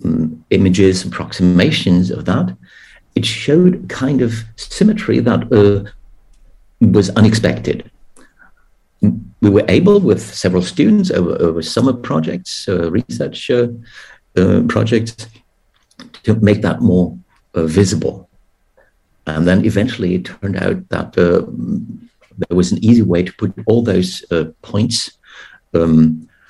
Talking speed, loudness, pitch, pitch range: 125 wpm, -15 LUFS, 100 Hz, 90-115 Hz